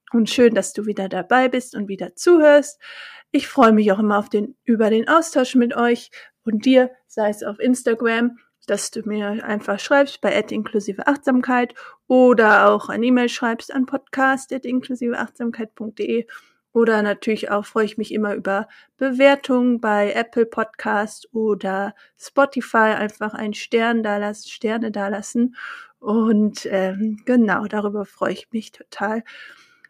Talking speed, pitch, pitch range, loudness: 145 wpm, 225 Hz, 210-255 Hz, -19 LUFS